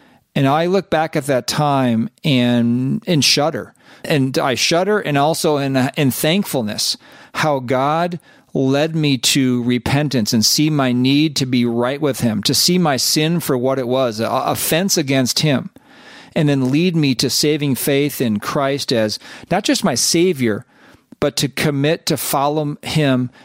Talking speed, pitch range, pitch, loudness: 170 wpm, 130-160 Hz, 145 Hz, -17 LUFS